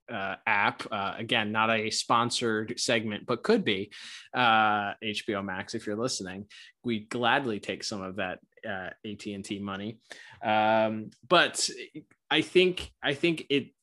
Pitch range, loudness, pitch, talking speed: 105-115 Hz, -28 LUFS, 110 Hz, 145 wpm